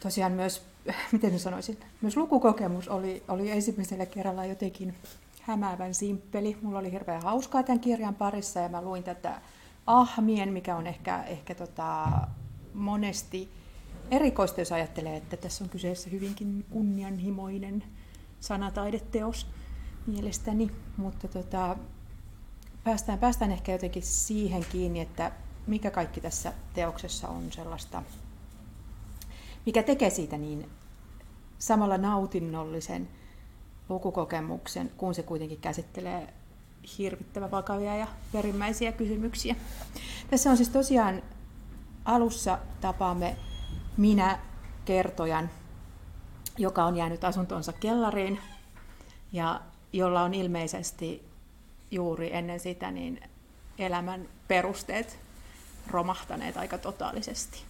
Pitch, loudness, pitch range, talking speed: 185 Hz, -31 LUFS, 165-205 Hz, 105 wpm